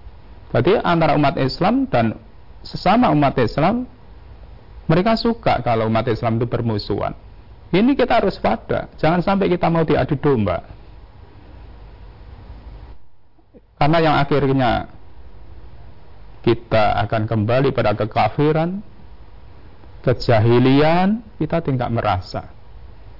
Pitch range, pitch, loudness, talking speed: 105-150 Hz, 120 Hz, -18 LUFS, 95 wpm